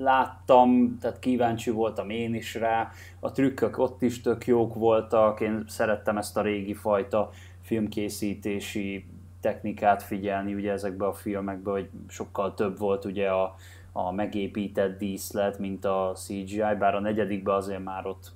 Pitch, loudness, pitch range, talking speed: 105 Hz, -27 LUFS, 100-110 Hz, 145 wpm